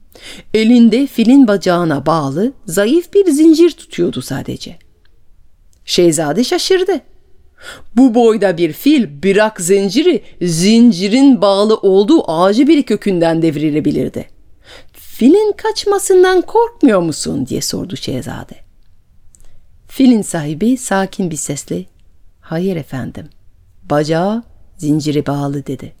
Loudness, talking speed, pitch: -13 LUFS, 95 wpm, 200 Hz